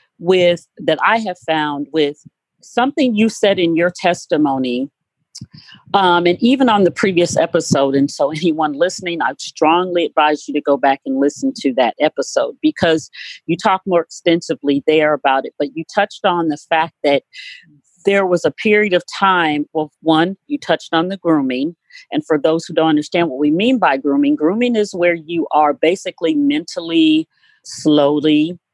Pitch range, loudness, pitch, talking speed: 150-195 Hz, -16 LUFS, 165 Hz, 170 wpm